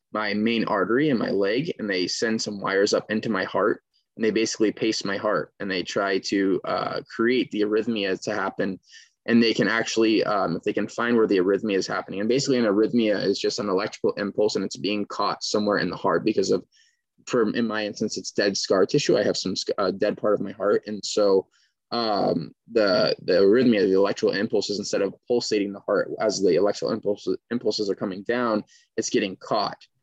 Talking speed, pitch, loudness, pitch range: 210 wpm, 110 Hz, -24 LUFS, 105-120 Hz